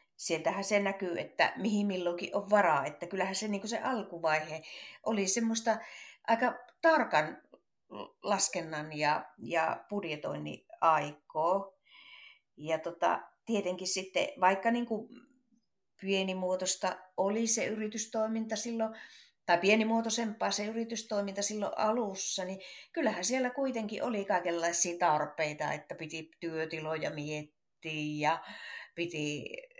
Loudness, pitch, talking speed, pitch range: -32 LUFS, 195 Hz, 110 wpm, 170-225 Hz